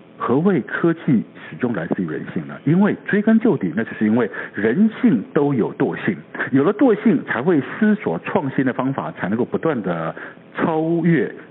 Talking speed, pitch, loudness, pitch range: 260 characters per minute, 170 Hz, -19 LUFS, 140-220 Hz